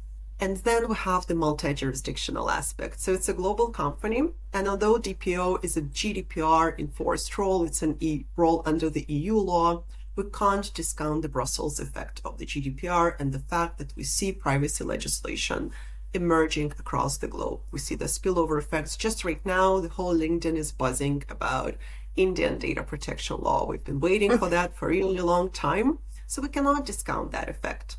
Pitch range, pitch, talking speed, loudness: 150-190 Hz, 170 Hz, 180 wpm, -27 LUFS